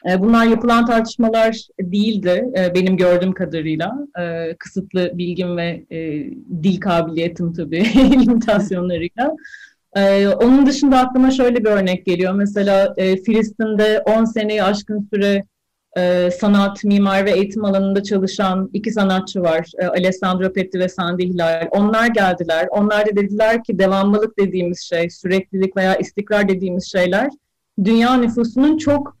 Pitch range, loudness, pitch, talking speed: 180-220 Hz, -17 LUFS, 195 Hz, 120 wpm